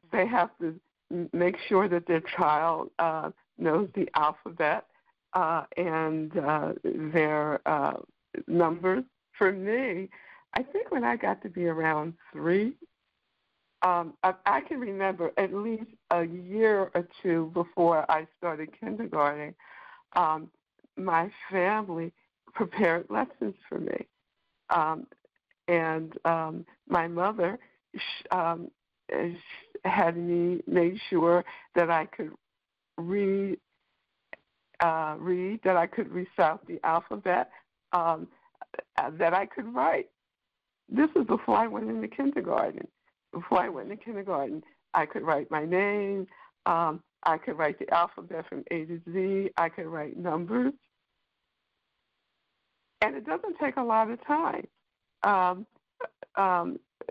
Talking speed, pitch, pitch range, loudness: 125 wpm, 175 Hz, 165-200 Hz, -29 LUFS